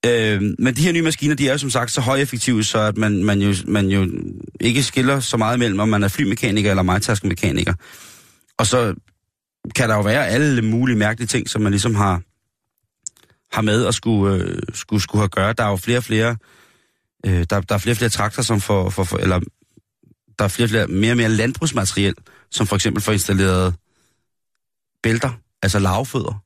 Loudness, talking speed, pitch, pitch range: -19 LUFS, 195 wpm, 110 Hz, 100-120 Hz